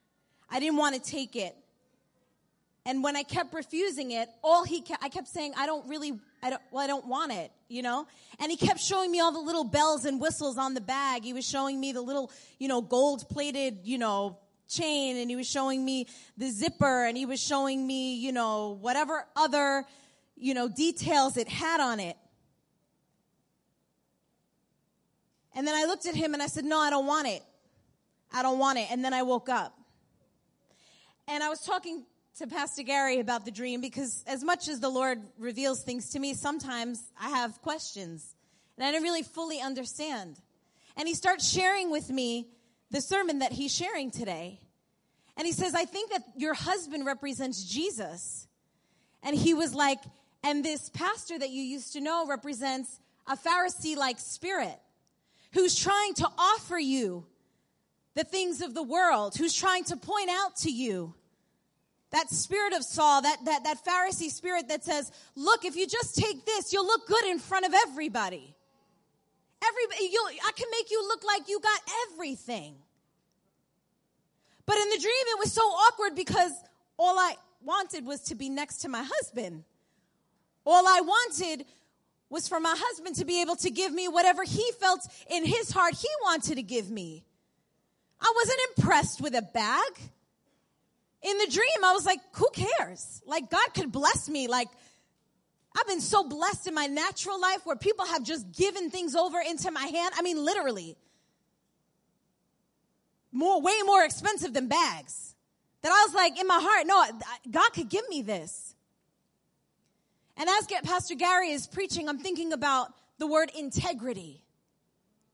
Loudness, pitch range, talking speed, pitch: -29 LUFS, 260-360 Hz, 175 wpm, 300 Hz